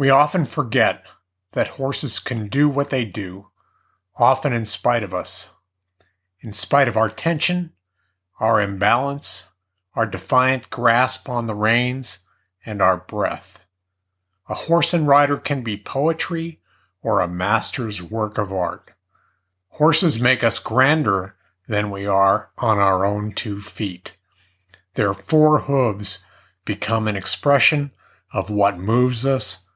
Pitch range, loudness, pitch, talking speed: 95-135 Hz, -20 LUFS, 110 Hz, 135 wpm